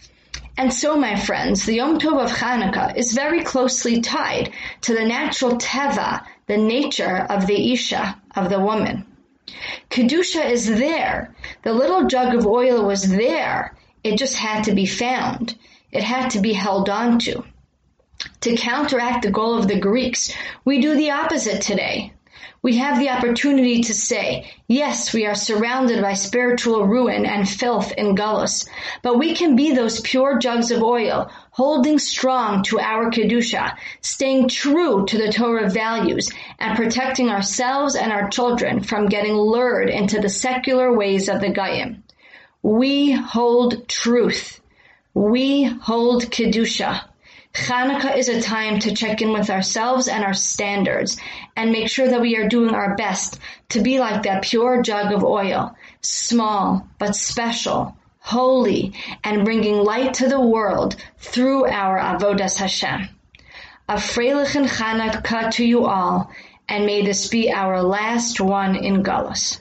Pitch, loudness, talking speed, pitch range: 235 Hz, -19 LUFS, 150 wpm, 210-255 Hz